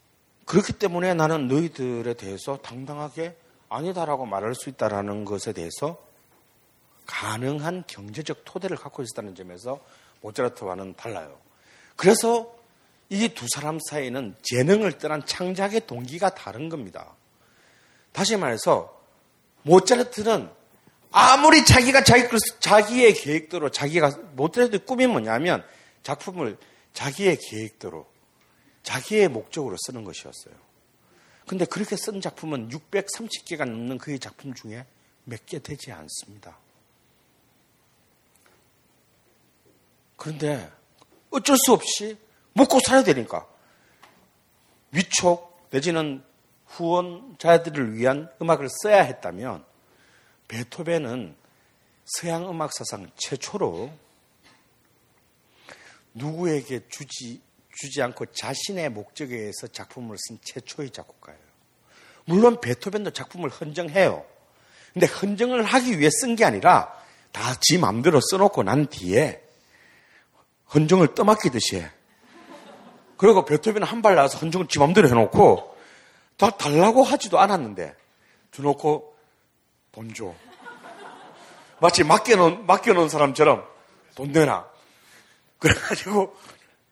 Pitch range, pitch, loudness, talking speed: 130-195 Hz, 155 Hz, -21 LUFS, 250 characters per minute